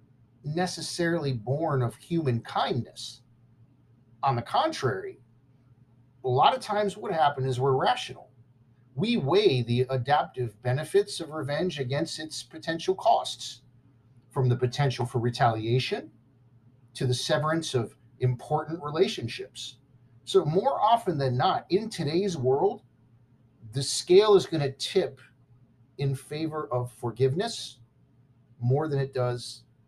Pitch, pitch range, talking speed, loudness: 130 Hz, 120-155 Hz, 125 wpm, -27 LUFS